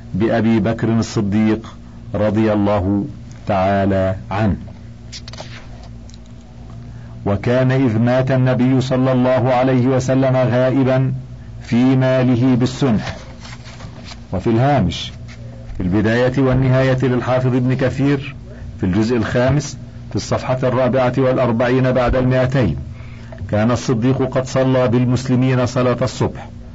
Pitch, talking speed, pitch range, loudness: 125 Hz, 95 wpm, 115-130 Hz, -17 LUFS